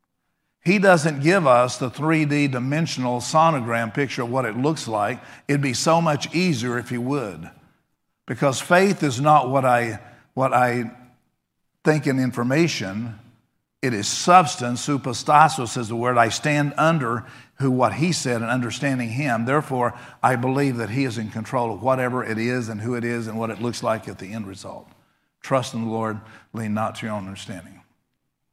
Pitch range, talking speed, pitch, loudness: 115-145 Hz, 180 wpm, 125 Hz, -21 LUFS